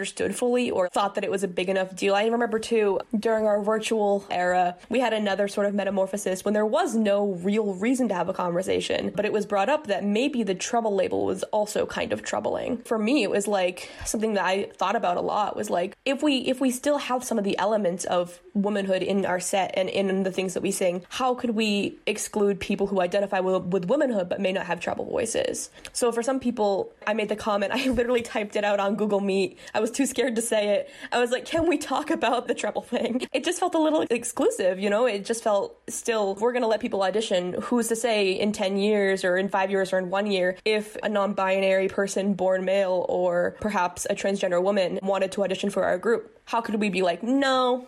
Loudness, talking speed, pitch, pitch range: -25 LUFS, 235 wpm, 205 Hz, 190-240 Hz